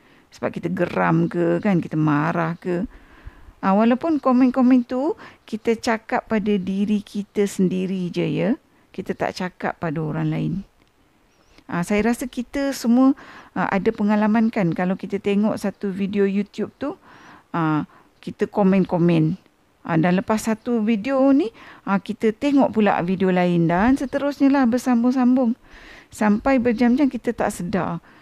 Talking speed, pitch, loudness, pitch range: 140 wpm, 210 Hz, -21 LUFS, 185-250 Hz